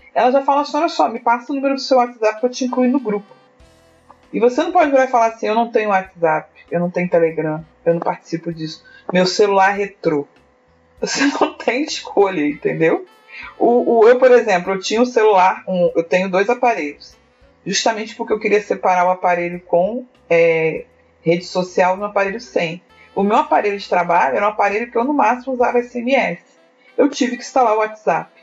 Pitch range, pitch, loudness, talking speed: 180-260 Hz, 215 Hz, -17 LUFS, 200 wpm